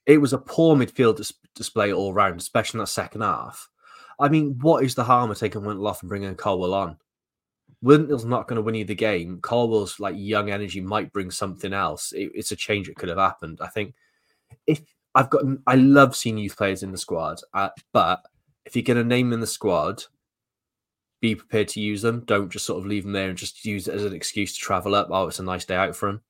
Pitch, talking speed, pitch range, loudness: 105 Hz, 240 wpm, 100-125 Hz, -23 LUFS